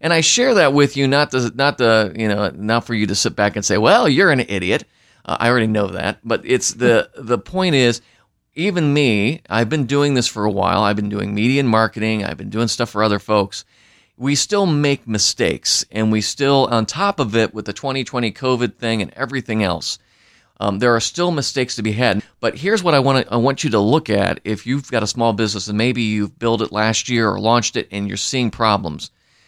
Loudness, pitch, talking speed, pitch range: -17 LUFS, 115 Hz, 235 wpm, 105-135 Hz